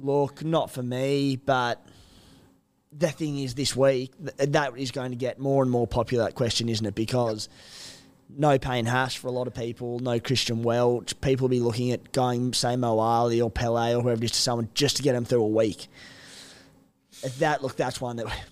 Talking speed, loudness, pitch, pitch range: 205 wpm, -26 LUFS, 125 Hz, 115-135 Hz